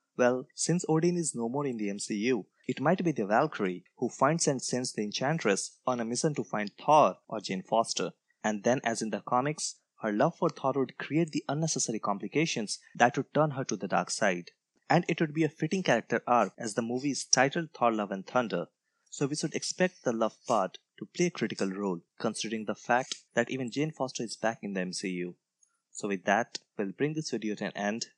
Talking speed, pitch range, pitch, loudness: 220 wpm, 110-150 Hz, 125 Hz, -30 LUFS